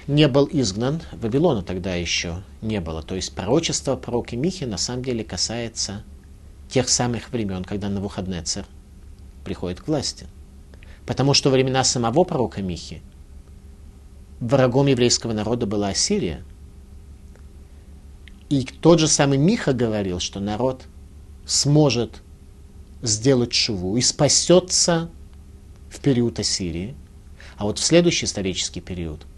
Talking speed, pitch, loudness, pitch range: 125 wpm, 95 Hz, -21 LUFS, 80-125 Hz